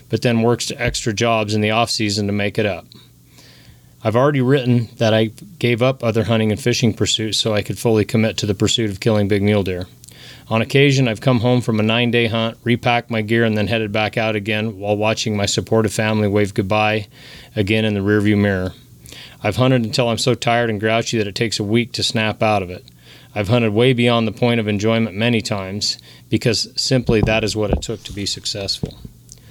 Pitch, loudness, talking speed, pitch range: 110 Hz, -18 LUFS, 220 wpm, 105-120 Hz